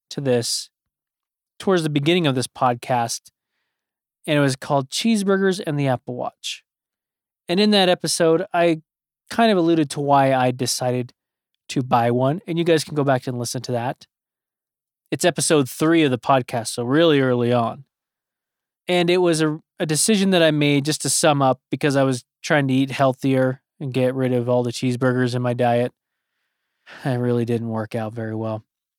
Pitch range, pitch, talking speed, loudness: 125-160 Hz, 135 Hz, 185 wpm, -20 LUFS